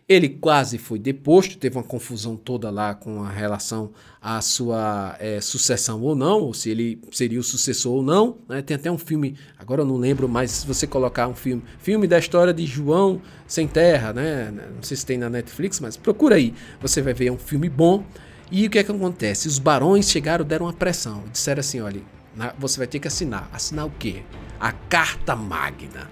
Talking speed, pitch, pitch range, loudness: 205 wpm, 130 Hz, 115-160 Hz, -22 LUFS